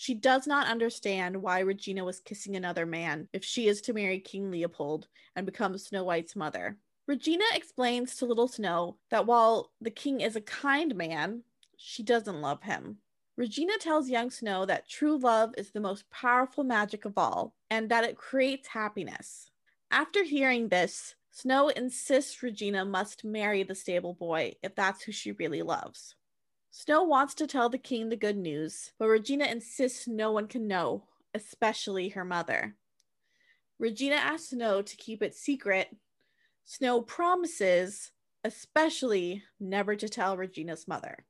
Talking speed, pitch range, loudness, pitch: 160 wpm, 190-255 Hz, -30 LUFS, 220 Hz